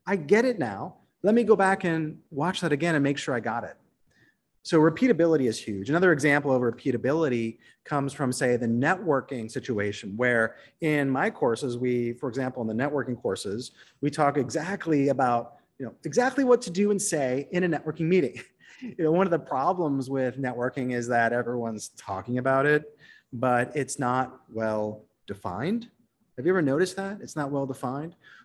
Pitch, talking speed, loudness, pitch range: 140 Hz, 185 wpm, -26 LUFS, 125-170 Hz